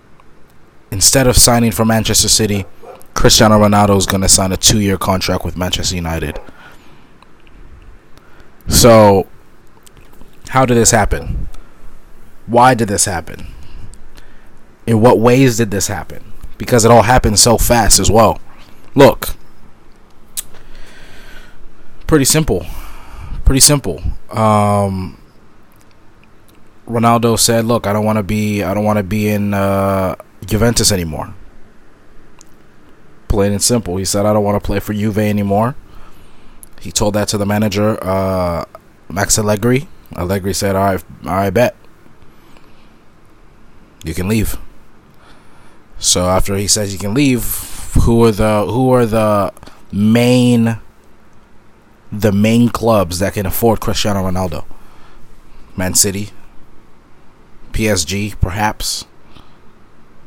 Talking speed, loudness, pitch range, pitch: 120 wpm, -13 LUFS, 95-115 Hz, 105 Hz